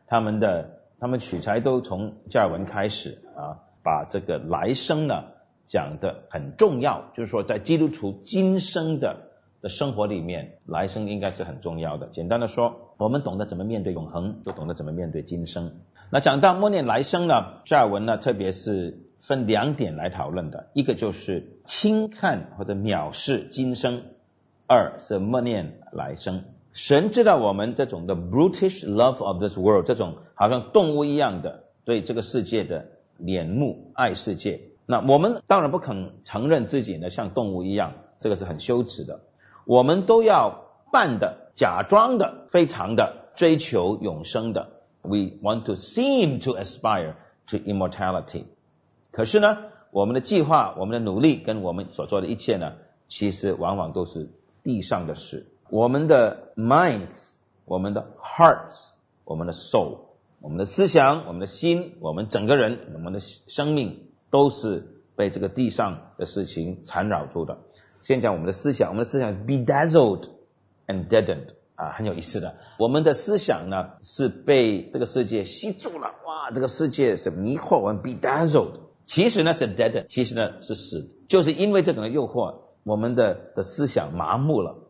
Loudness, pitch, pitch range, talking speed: -24 LUFS, 115 Hz, 100-150 Hz, 305 characters per minute